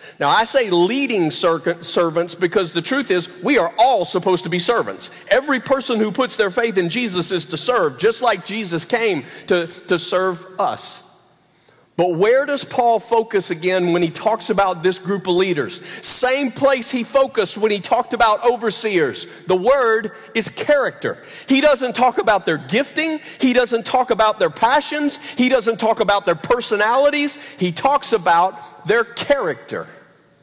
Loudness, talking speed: -18 LUFS, 170 wpm